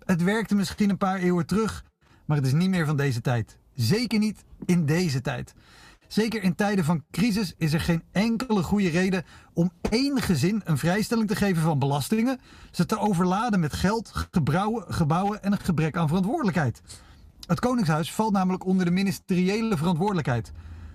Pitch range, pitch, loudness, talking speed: 160-210 Hz, 185 Hz, -25 LUFS, 170 wpm